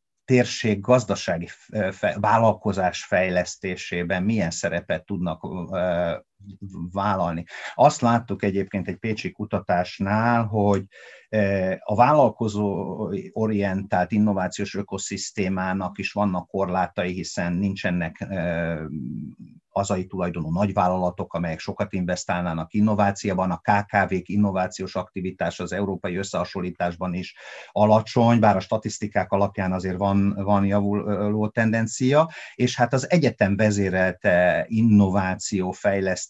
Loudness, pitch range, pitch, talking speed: -23 LUFS, 90-105 Hz, 100 Hz, 95 wpm